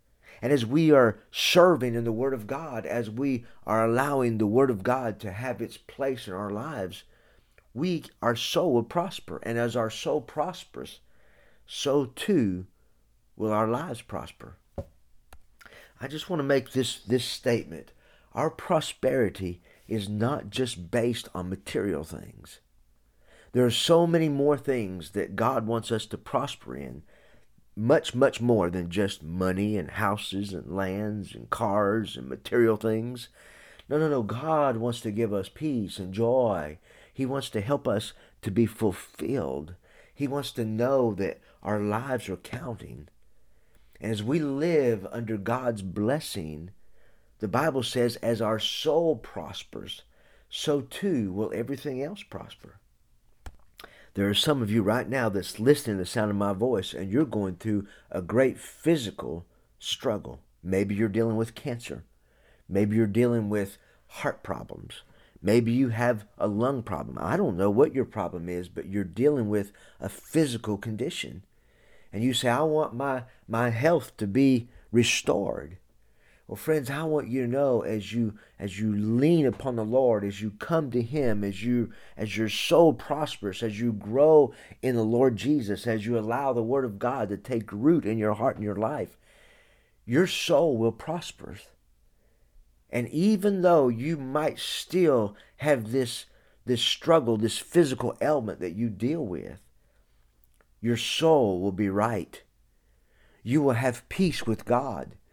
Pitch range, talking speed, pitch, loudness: 105-130 Hz, 160 wpm, 115 Hz, -27 LUFS